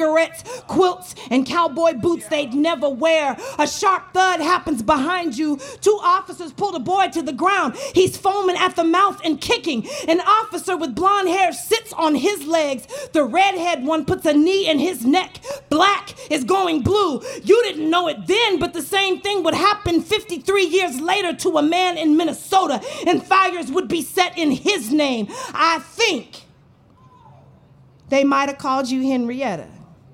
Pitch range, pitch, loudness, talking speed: 300-380 Hz, 335 Hz, -19 LUFS, 170 wpm